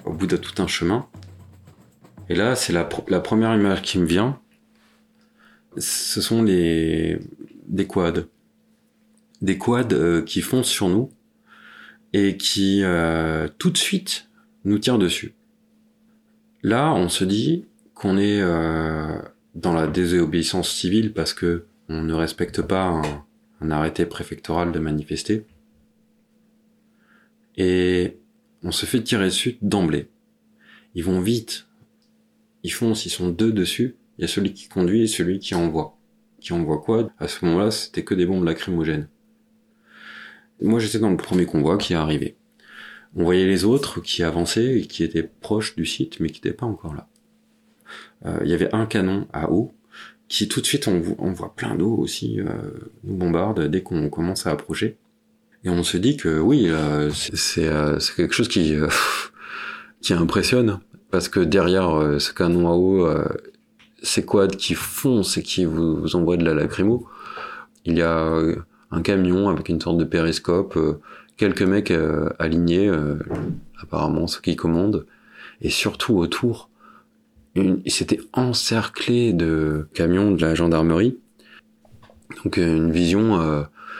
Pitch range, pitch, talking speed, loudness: 85-125 Hz, 95 Hz, 155 wpm, -21 LUFS